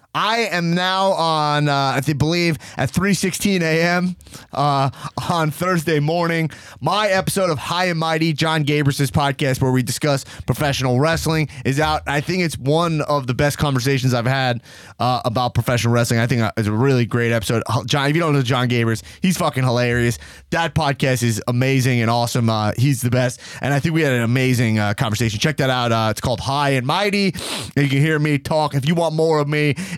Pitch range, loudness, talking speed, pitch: 125-160 Hz, -19 LUFS, 200 wpm, 140 Hz